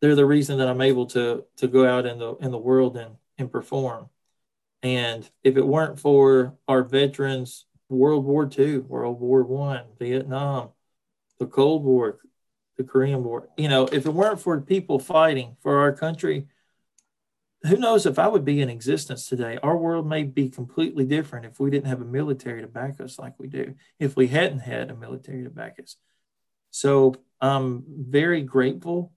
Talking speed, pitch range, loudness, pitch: 185 wpm, 130-145 Hz, -23 LUFS, 135 Hz